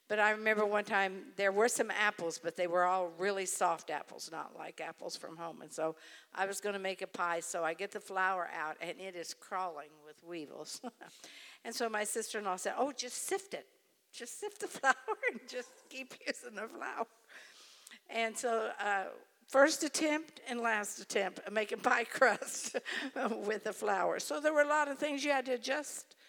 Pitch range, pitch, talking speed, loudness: 190-260 Hz, 215 Hz, 205 wpm, -35 LUFS